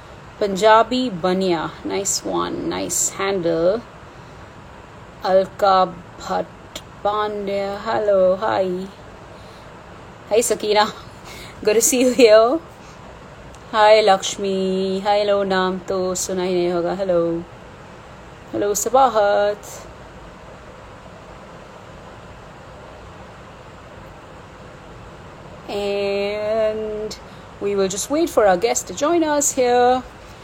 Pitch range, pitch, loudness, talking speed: 190-215 Hz, 200 Hz, -19 LUFS, 85 wpm